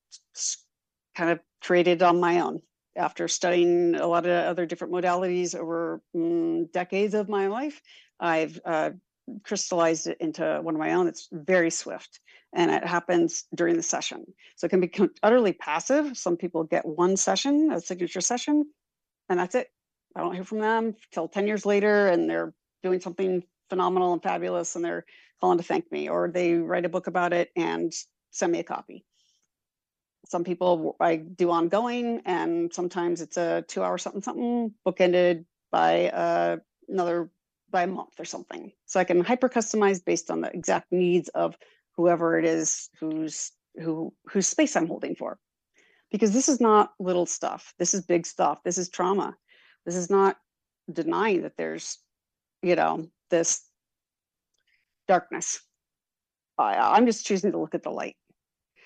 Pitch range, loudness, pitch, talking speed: 170-200 Hz, -26 LUFS, 180 Hz, 165 wpm